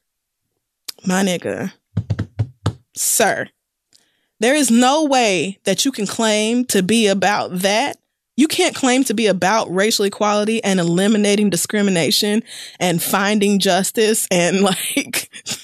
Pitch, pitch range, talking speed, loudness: 200 Hz, 180-225 Hz, 120 wpm, -17 LUFS